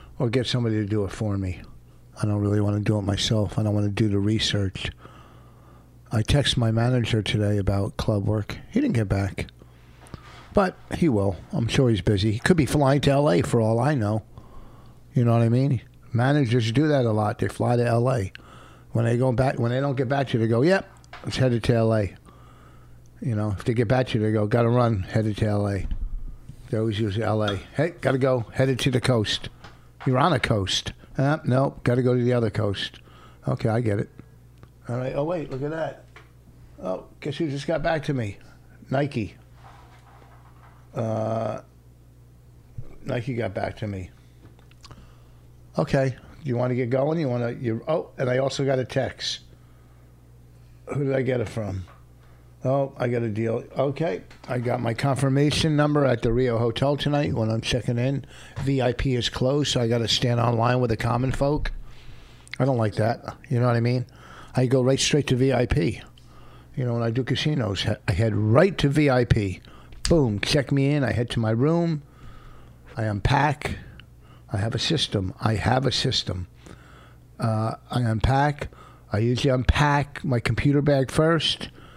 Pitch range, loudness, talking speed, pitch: 105-135 Hz, -24 LUFS, 190 wpm, 120 Hz